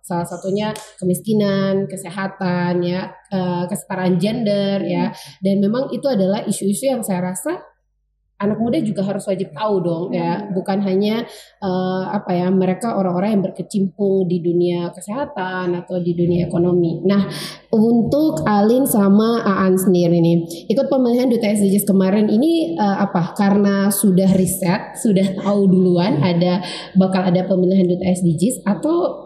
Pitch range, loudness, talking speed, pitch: 180-205 Hz, -18 LUFS, 140 wpm, 195 Hz